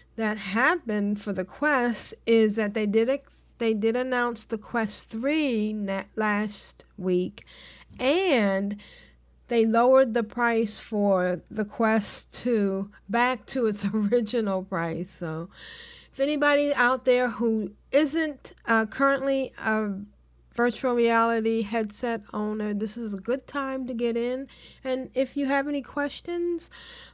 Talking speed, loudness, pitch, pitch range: 130 wpm, -26 LUFS, 230 Hz, 210-260 Hz